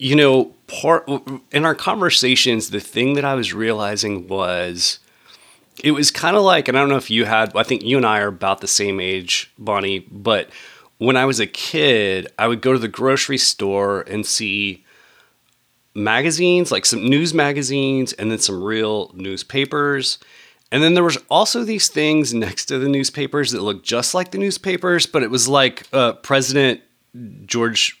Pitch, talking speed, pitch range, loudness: 130 Hz, 180 wpm, 105-145 Hz, -17 LUFS